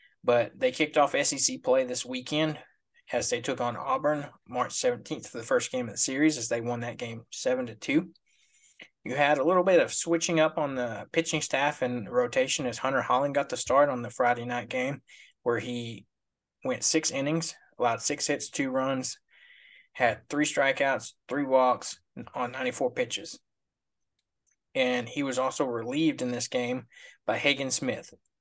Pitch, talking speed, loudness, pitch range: 145 Hz, 175 wpm, -28 LUFS, 125-175 Hz